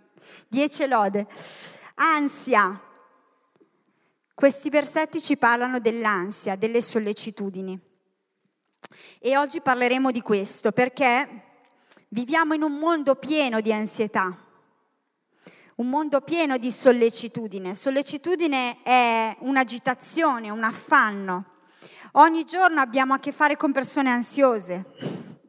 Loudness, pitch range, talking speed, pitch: -22 LUFS, 220-285 Hz, 100 wpm, 250 Hz